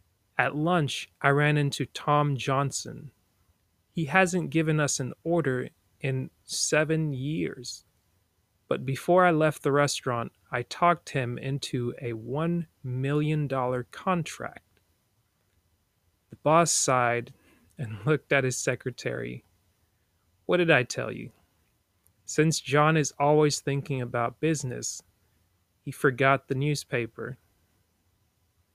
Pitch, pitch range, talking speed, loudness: 130 Hz, 100-150 Hz, 115 wpm, -27 LUFS